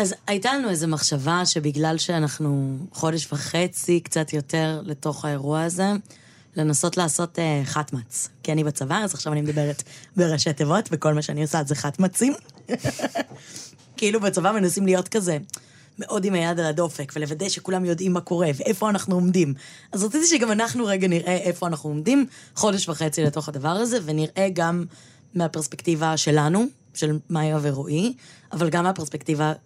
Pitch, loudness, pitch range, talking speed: 165 Hz, -23 LUFS, 150-185 Hz, 150 wpm